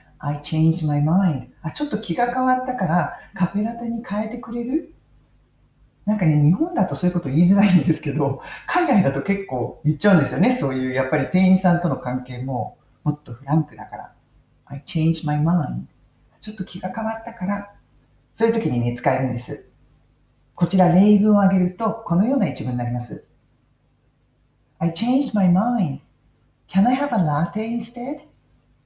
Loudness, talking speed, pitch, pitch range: -21 LUFS, 420 characters per minute, 170 Hz, 135-205 Hz